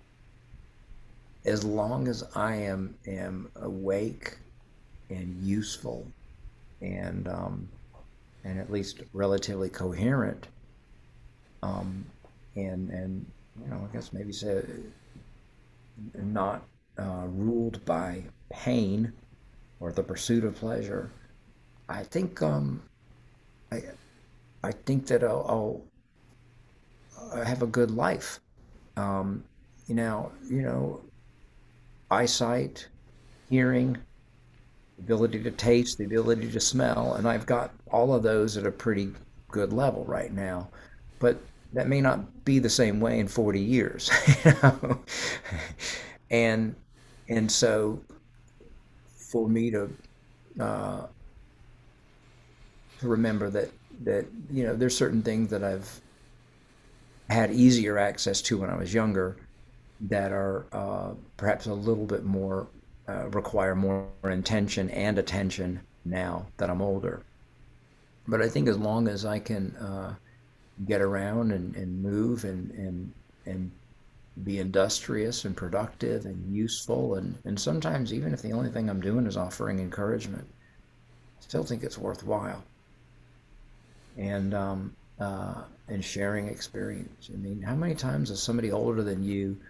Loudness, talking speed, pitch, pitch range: -29 LUFS, 125 wpm, 105 Hz, 95-120 Hz